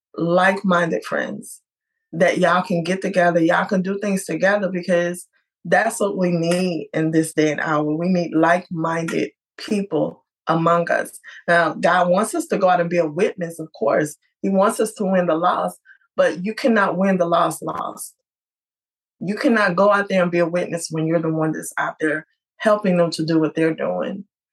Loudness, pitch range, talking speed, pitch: -20 LUFS, 165-195 Hz, 190 wpm, 175 Hz